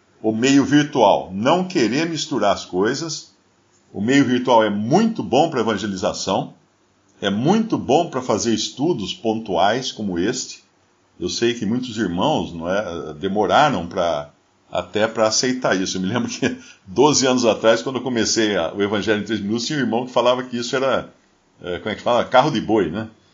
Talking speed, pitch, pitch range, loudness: 175 wpm, 115 Hz, 110-135 Hz, -19 LUFS